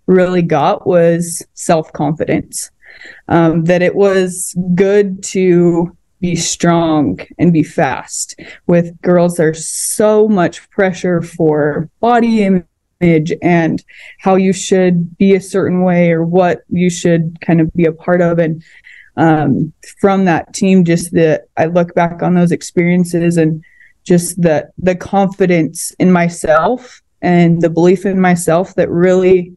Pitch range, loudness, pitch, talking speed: 165-185 Hz, -13 LUFS, 175 Hz, 140 wpm